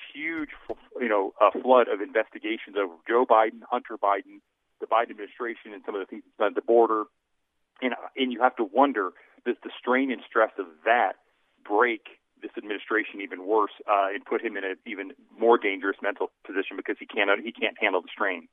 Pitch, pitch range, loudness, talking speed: 115 Hz, 100-130 Hz, -26 LUFS, 195 wpm